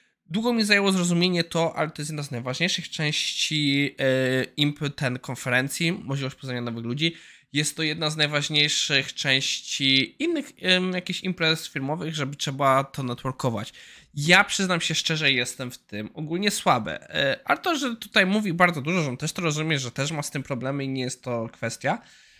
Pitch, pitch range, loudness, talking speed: 150 Hz, 135-175 Hz, -24 LUFS, 175 wpm